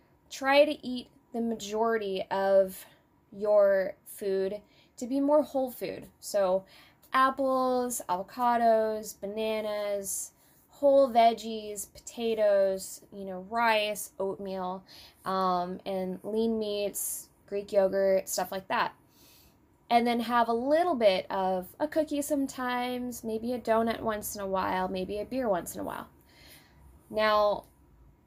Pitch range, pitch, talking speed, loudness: 195-245 Hz, 215 Hz, 125 wpm, -29 LUFS